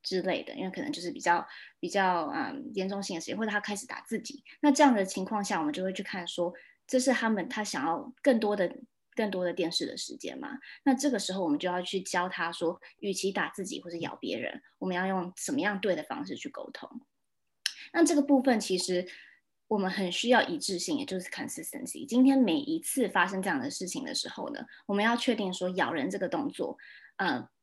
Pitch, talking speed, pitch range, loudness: 220 Hz, 340 characters per minute, 185-275 Hz, -30 LUFS